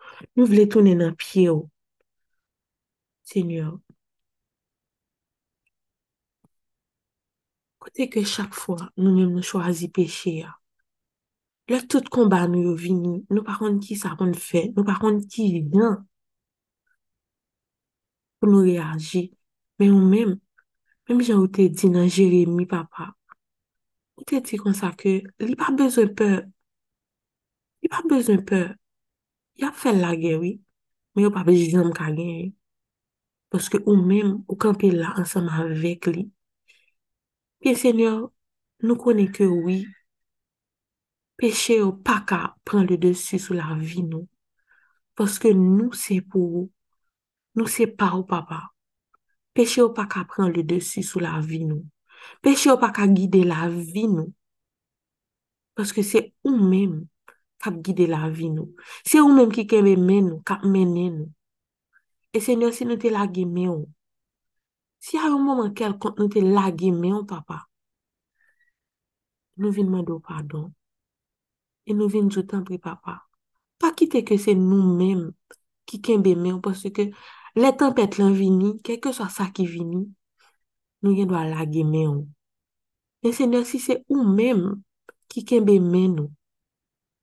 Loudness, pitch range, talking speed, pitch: -21 LUFS, 180-225 Hz, 150 wpm, 195 Hz